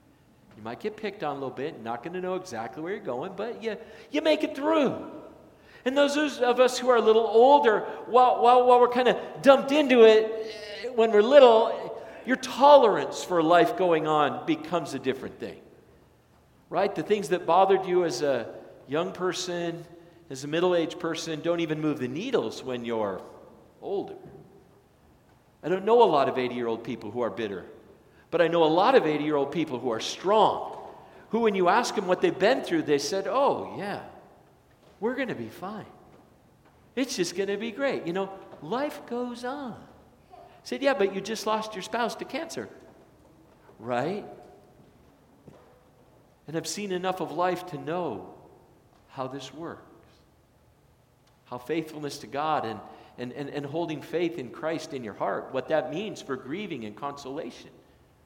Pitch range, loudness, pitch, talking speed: 155-235 Hz, -25 LUFS, 180 Hz, 175 wpm